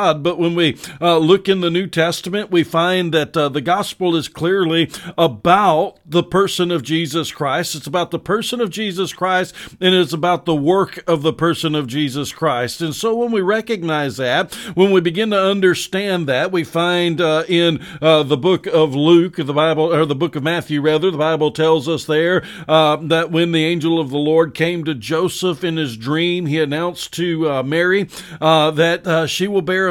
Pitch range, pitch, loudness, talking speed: 155-180 Hz, 165 Hz, -17 LUFS, 205 wpm